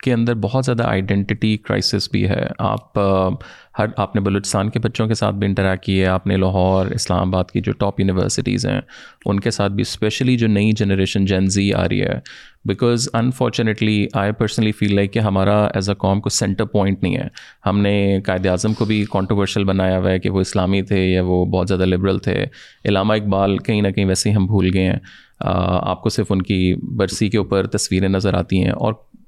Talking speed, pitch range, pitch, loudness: 215 wpm, 95-110 Hz, 100 Hz, -18 LUFS